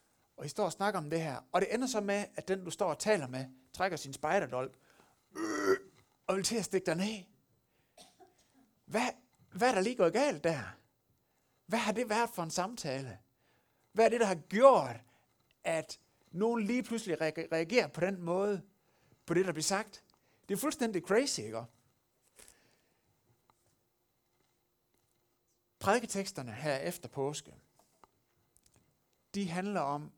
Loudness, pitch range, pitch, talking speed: -33 LUFS, 130-205 Hz, 170 Hz, 150 wpm